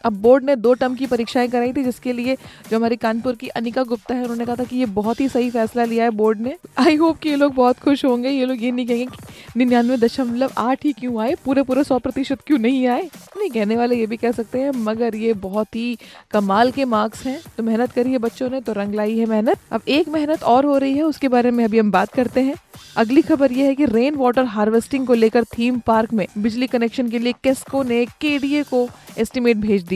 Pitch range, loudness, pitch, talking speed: 230-265 Hz, -19 LUFS, 245 Hz, 245 wpm